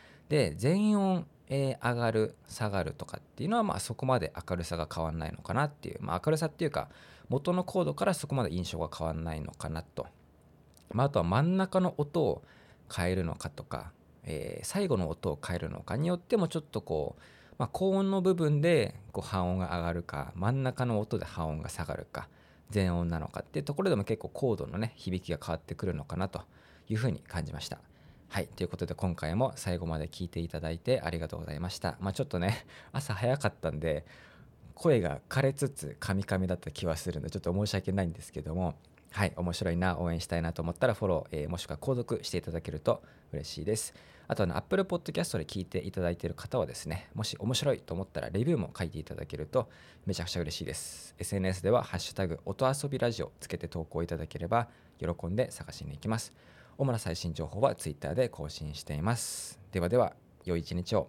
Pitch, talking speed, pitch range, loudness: 95 Hz, 435 characters per minute, 85-125 Hz, -33 LUFS